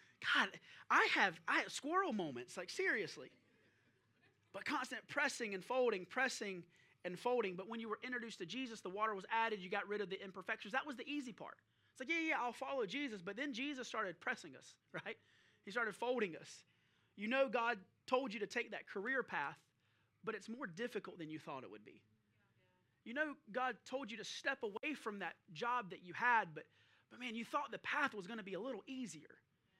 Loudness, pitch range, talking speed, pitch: -41 LUFS, 200-260 Hz, 210 wpm, 235 Hz